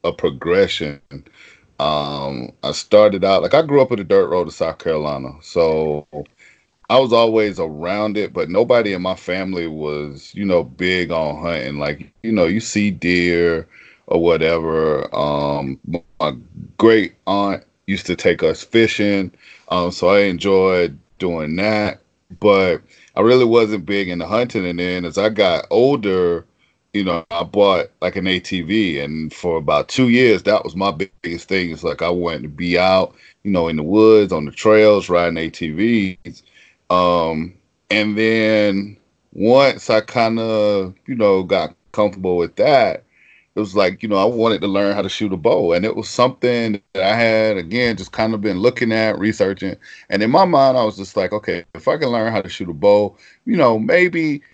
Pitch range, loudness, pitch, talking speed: 85-110 Hz, -17 LUFS, 100 Hz, 185 wpm